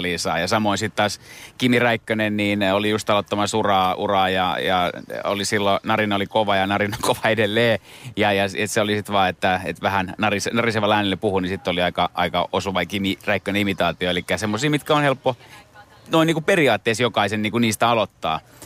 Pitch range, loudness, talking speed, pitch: 95-115 Hz, -20 LUFS, 195 wpm, 105 Hz